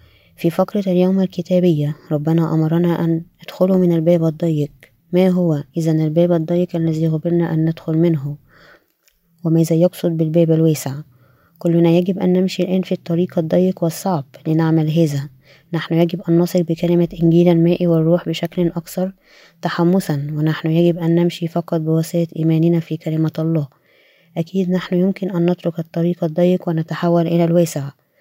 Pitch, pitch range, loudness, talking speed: 170 Hz, 160-175 Hz, -17 LUFS, 145 wpm